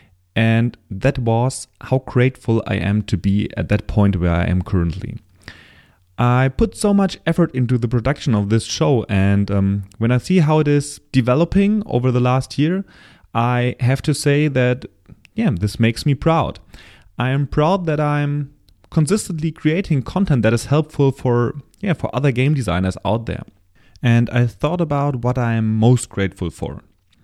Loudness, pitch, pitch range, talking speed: -18 LUFS, 125 Hz, 105-145 Hz, 175 wpm